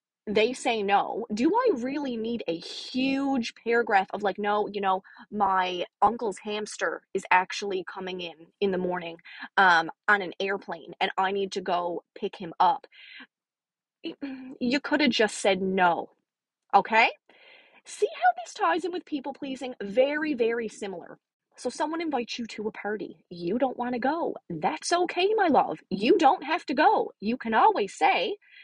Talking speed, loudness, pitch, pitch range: 170 wpm, -26 LUFS, 235 Hz, 195-305 Hz